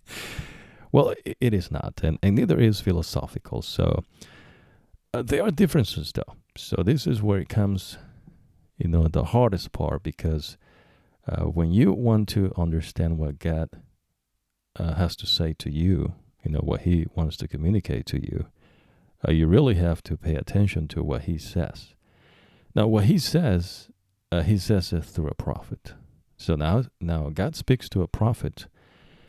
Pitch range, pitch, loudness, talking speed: 80-105 Hz, 90 Hz, -25 LUFS, 160 wpm